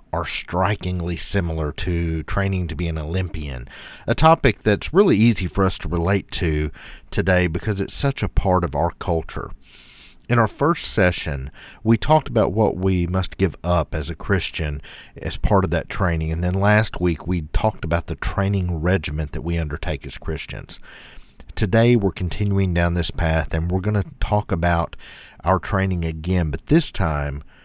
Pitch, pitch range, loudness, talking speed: 90 Hz, 80-100 Hz, -21 LUFS, 175 wpm